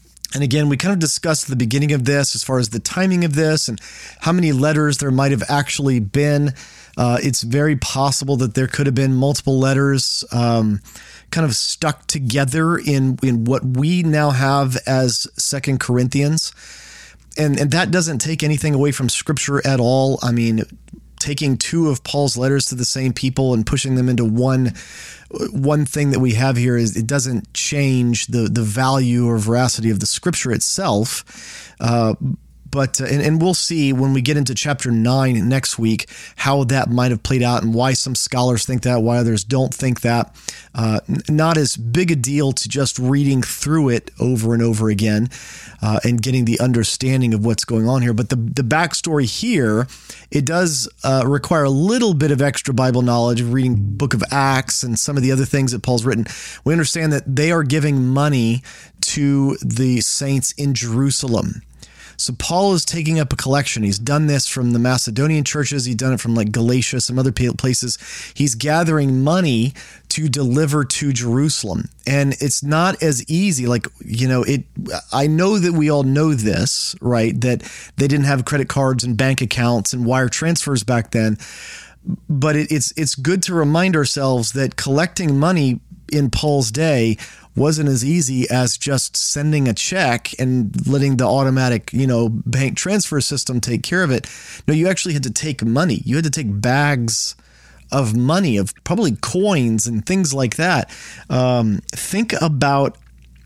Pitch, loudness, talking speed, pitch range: 135 Hz, -18 LUFS, 185 wpm, 120-145 Hz